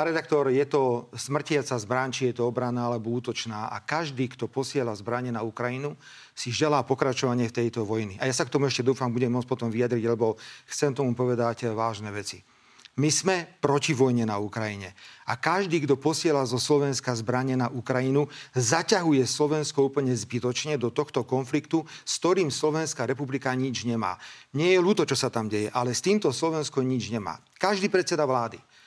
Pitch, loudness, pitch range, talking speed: 130 Hz, -27 LUFS, 120-145 Hz, 180 wpm